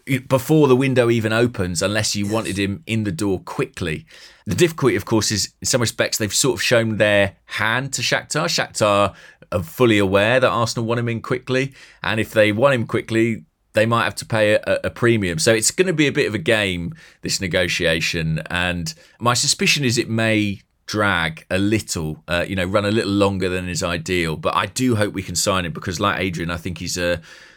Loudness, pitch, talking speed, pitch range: -19 LUFS, 110 Hz, 215 wpm, 95-120 Hz